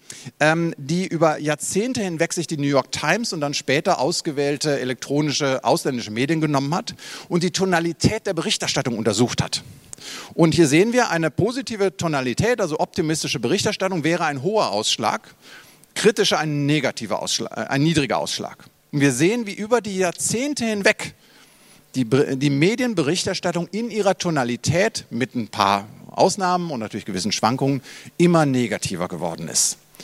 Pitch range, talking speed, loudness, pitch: 140-185 Hz, 140 wpm, -21 LUFS, 160 Hz